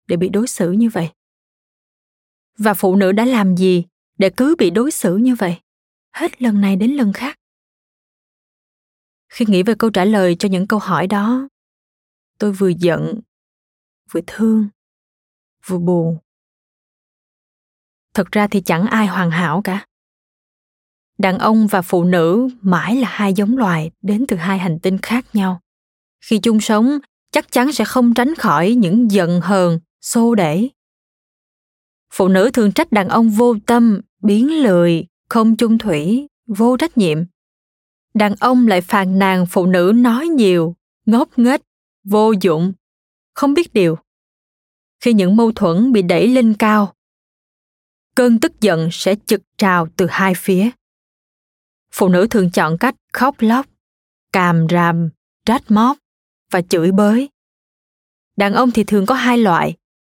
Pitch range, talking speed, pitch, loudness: 185-235 Hz, 150 wpm, 205 Hz, -15 LUFS